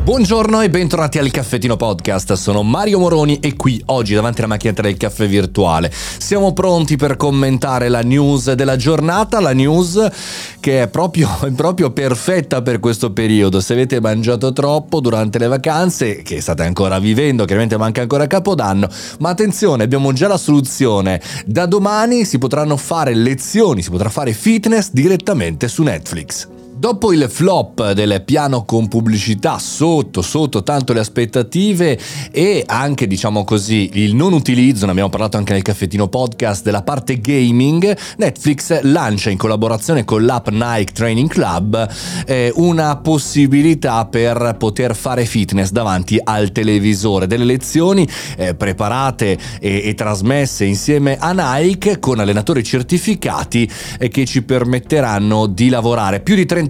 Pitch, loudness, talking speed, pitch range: 125 Hz, -15 LUFS, 150 wpm, 110-150 Hz